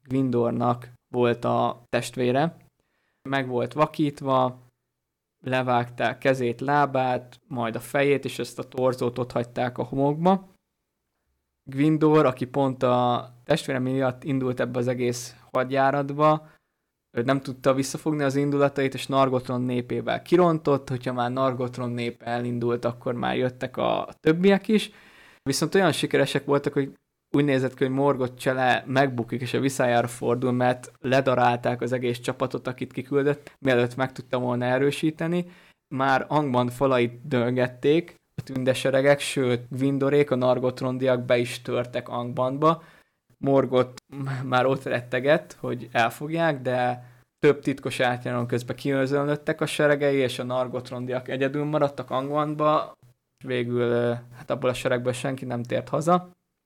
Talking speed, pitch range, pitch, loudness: 130 wpm, 125-140 Hz, 130 Hz, -25 LUFS